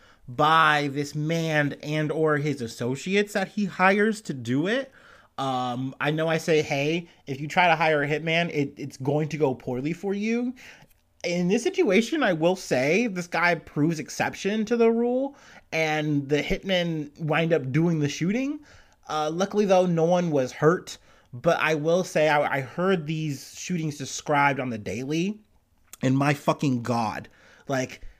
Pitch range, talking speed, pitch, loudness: 145-180 Hz, 170 wpm, 155 Hz, -25 LUFS